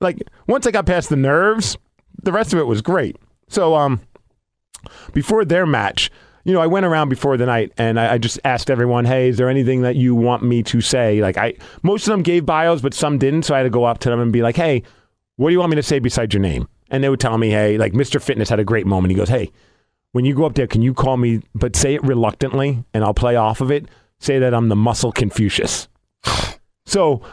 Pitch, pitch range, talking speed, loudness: 125 Hz, 115-145 Hz, 255 wpm, -17 LUFS